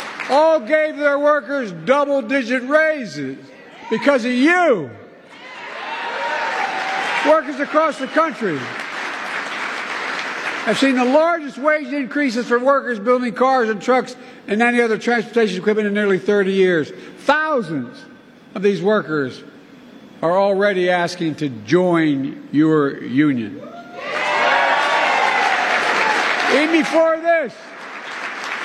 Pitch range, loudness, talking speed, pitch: 205-290 Hz, -18 LUFS, 105 wpm, 255 Hz